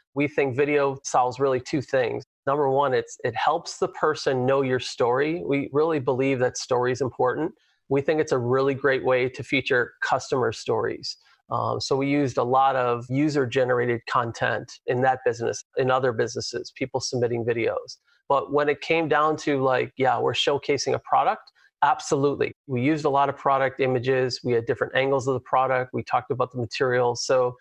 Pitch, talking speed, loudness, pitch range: 135 Hz, 190 wpm, -24 LUFS, 125-145 Hz